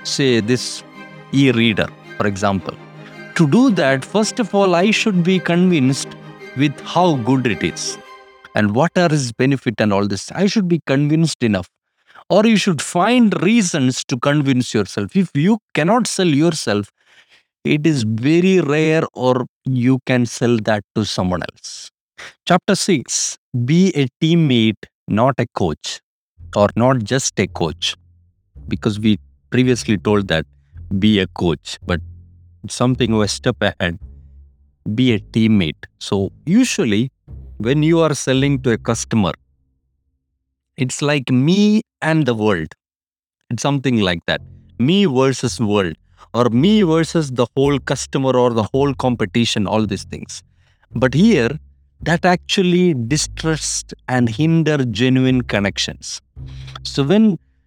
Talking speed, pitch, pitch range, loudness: 140 wpm, 125 Hz, 105-160 Hz, -17 LUFS